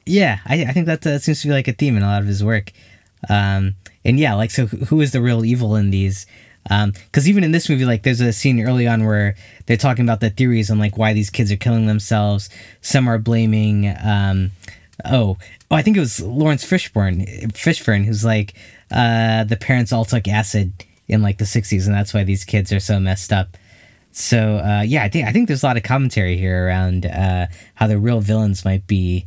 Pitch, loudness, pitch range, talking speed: 110 Hz, -17 LUFS, 100-120 Hz, 230 wpm